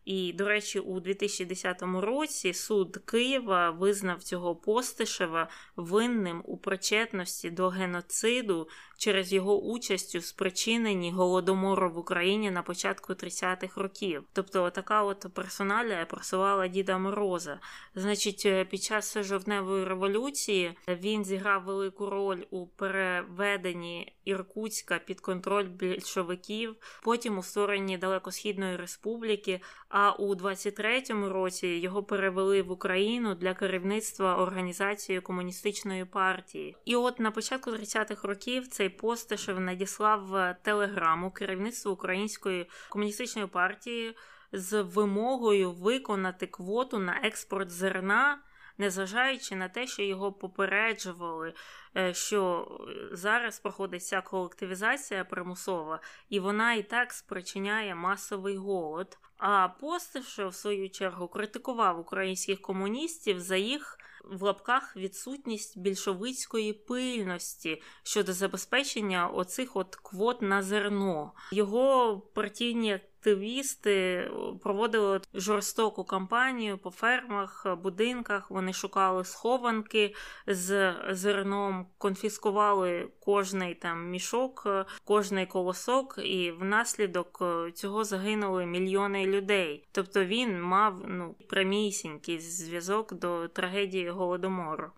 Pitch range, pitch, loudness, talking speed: 185-215 Hz, 195 Hz, -31 LUFS, 105 wpm